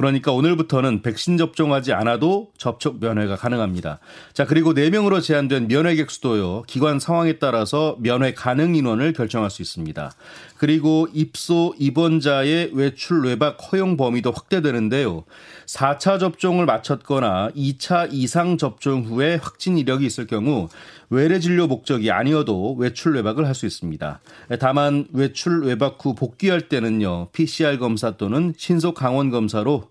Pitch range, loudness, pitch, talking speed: 120-160 Hz, -20 LUFS, 140 Hz, 330 characters per minute